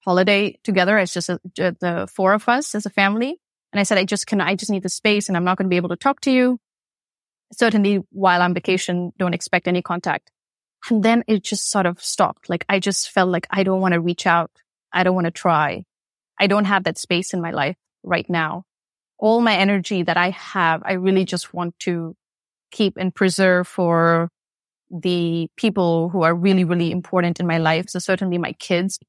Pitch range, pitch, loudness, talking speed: 175-200 Hz, 185 Hz, -20 LUFS, 215 wpm